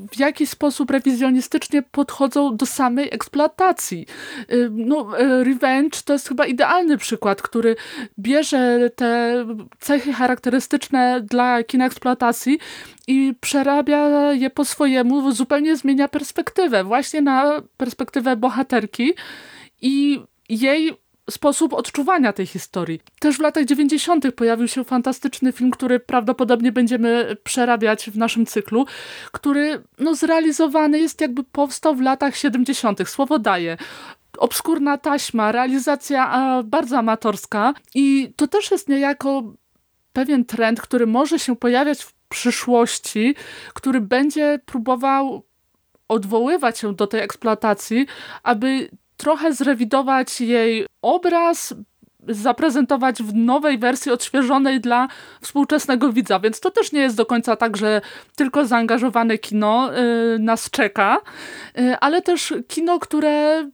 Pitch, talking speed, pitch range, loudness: 265 Hz, 115 wpm, 240-290 Hz, -19 LUFS